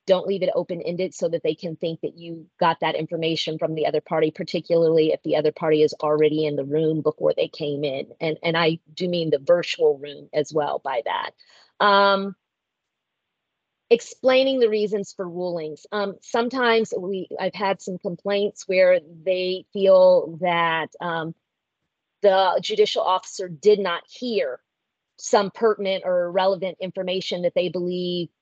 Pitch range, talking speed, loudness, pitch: 165-200 Hz, 165 wpm, -22 LUFS, 185 Hz